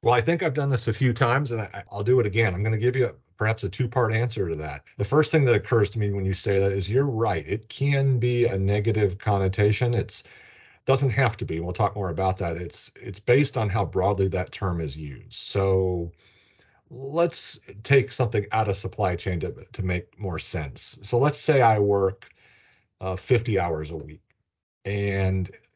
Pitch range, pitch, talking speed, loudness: 95-125 Hz, 105 Hz, 215 wpm, -25 LUFS